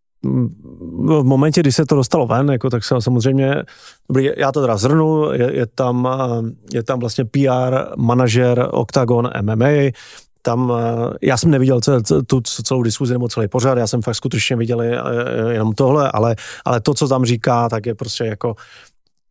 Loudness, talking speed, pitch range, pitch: -17 LUFS, 165 wpm, 120-135 Hz, 125 Hz